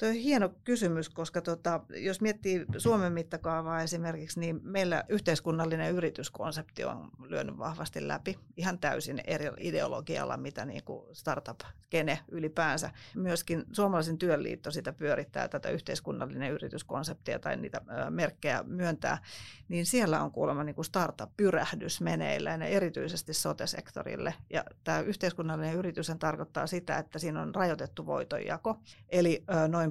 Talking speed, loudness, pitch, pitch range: 125 wpm, -33 LUFS, 165 Hz, 160-180 Hz